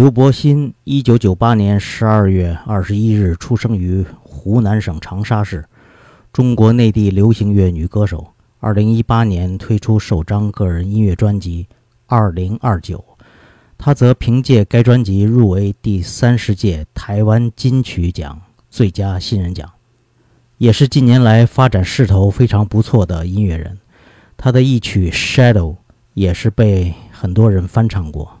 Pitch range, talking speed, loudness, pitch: 95-115 Hz, 235 characters per minute, -14 LUFS, 105 Hz